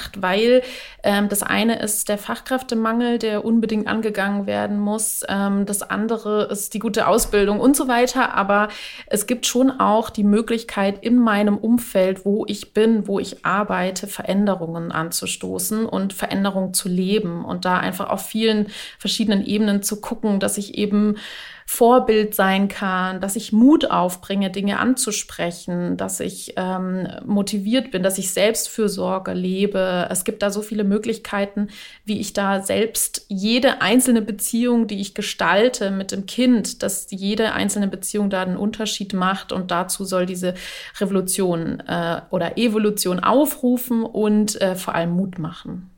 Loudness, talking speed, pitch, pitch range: -20 LUFS, 155 wpm, 205 Hz, 190-220 Hz